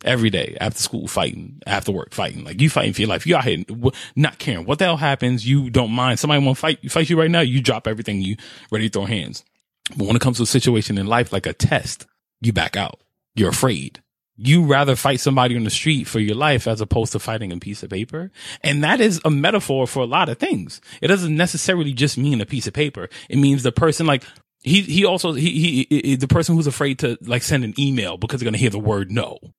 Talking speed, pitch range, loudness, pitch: 250 wpm, 115-150 Hz, -19 LUFS, 130 Hz